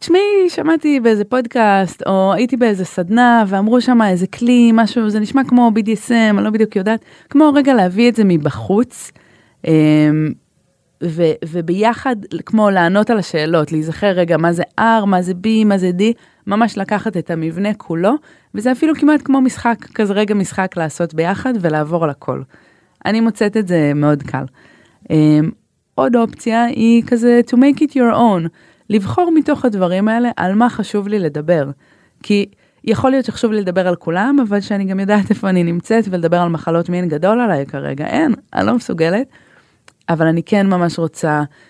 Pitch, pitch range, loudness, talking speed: 210 Hz, 170-235 Hz, -15 LUFS, 170 wpm